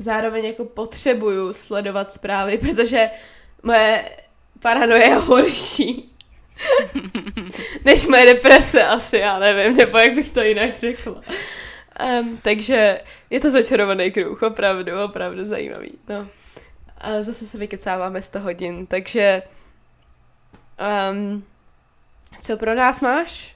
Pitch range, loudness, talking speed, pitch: 200-245 Hz, -17 LUFS, 110 wpm, 220 Hz